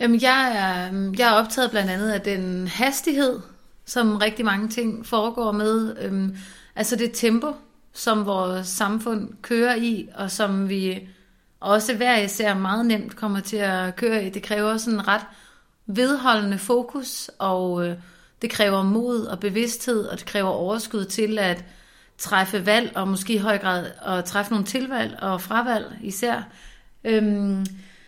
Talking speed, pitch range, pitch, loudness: 145 wpm, 195-230 Hz, 215 Hz, -23 LUFS